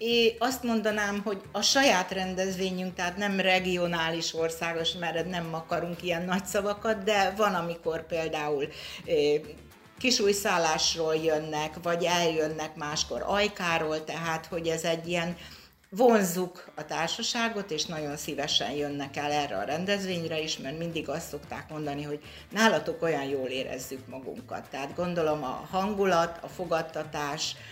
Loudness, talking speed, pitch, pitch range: -29 LUFS, 140 wpm, 170 Hz, 155-190 Hz